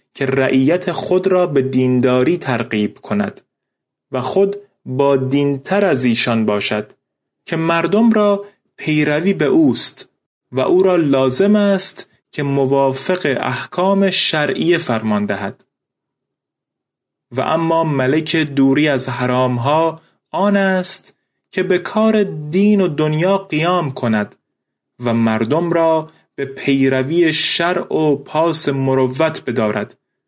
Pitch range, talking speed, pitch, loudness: 130-185 Hz, 115 wpm, 155 Hz, -16 LUFS